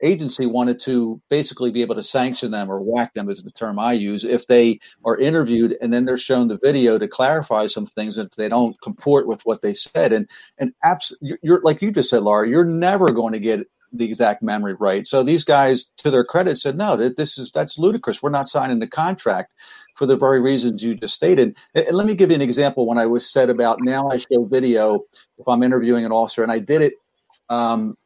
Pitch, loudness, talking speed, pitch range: 125 Hz, -19 LUFS, 235 wpm, 115-145 Hz